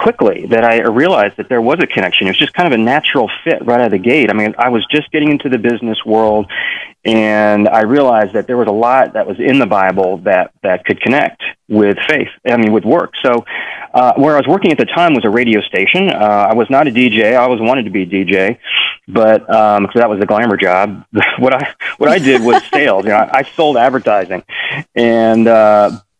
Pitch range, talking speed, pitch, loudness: 105-120 Hz, 235 wpm, 110 Hz, -11 LUFS